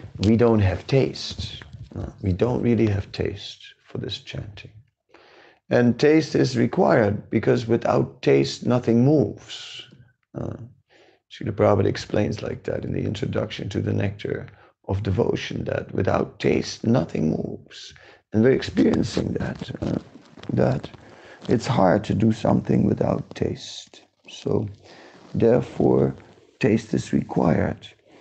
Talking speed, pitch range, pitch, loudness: 130 wpm, 100-120 Hz, 110 Hz, -23 LUFS